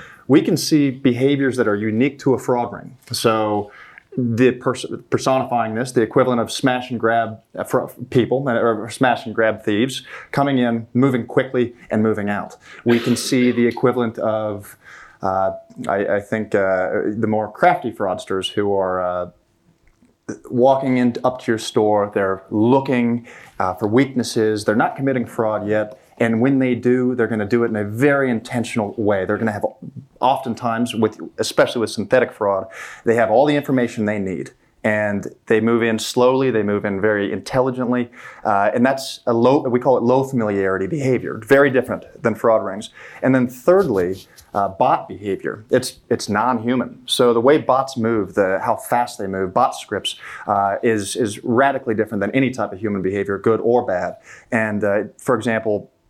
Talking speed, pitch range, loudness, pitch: 175 wpm, 105-125 Hz, -19 LUFS, 115 Hz